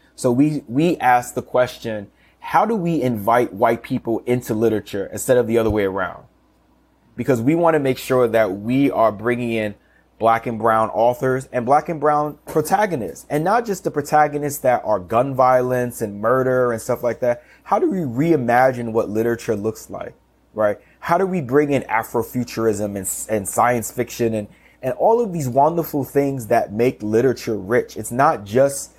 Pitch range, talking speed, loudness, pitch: 115-140 Hz, 180 wpm, -19 LUFS, 125 Hz